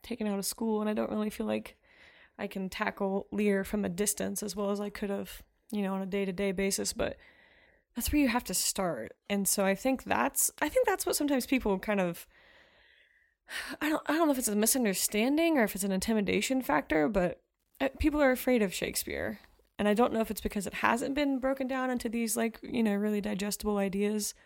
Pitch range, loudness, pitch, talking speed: 200-255 Hz, -30 LUFS, 215 Hz, 225 wpm